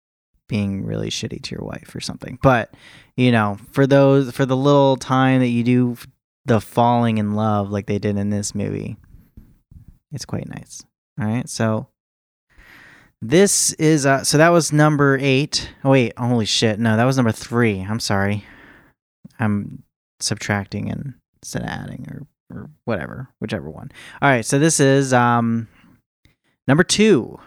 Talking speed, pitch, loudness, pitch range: 160 wpm, 120 Hz, -18 LUFS, 105-135 Hz